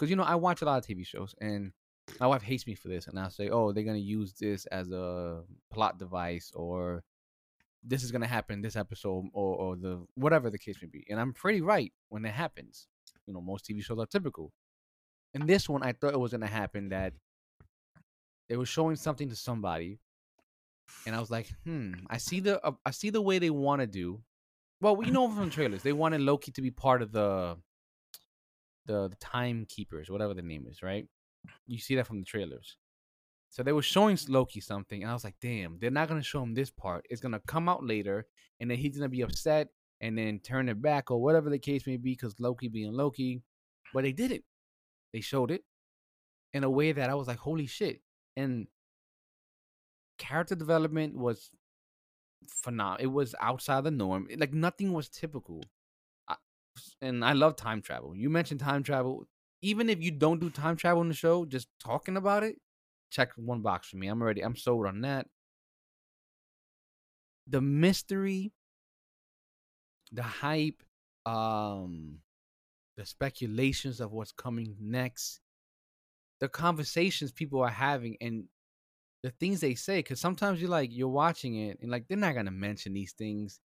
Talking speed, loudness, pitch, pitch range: 185 wpm, -32 LUFS, 120 Hz, 100-145 Hz